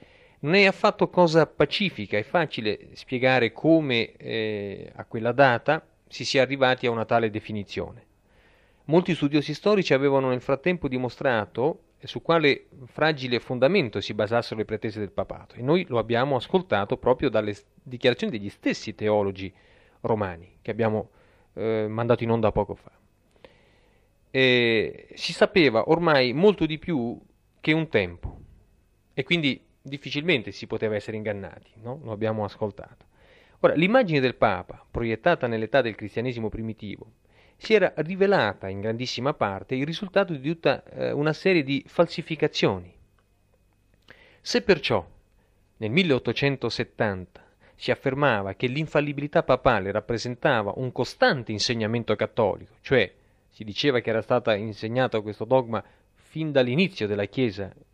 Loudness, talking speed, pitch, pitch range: -24 LUFS, 135 wpm, 120 Hz, 105-145 Hz